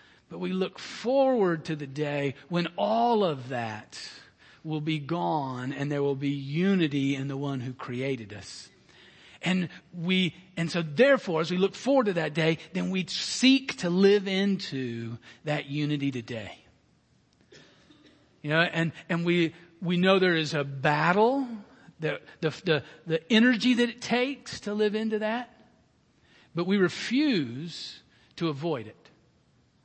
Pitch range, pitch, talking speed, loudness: 145-195 Hz, 170 Hz, 150 wpm, -27 LUFS